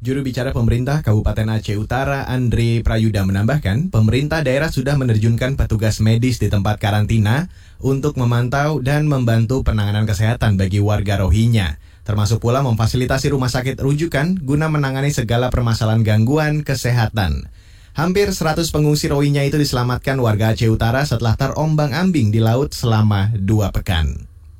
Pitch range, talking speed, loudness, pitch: 110-140 Hz, 135 wpm, -17 LUFS, 120 Hz